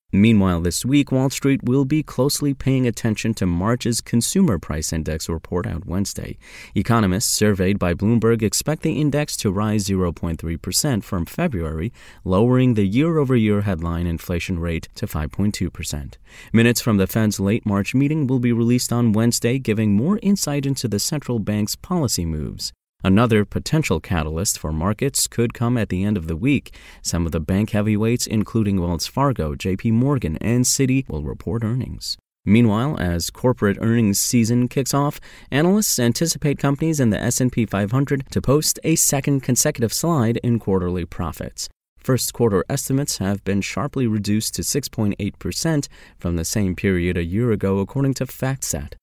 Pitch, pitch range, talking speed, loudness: 110 Hz, 95-130 Hz, 160 wpm, -20 LUFS